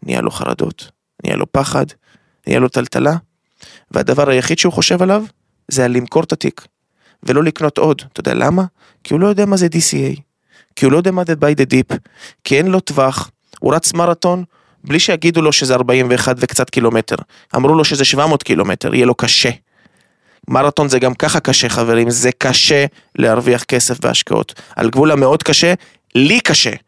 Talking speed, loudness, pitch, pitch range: 180 wpm, -13 LUFS, 140 Hz, 125-165 Hz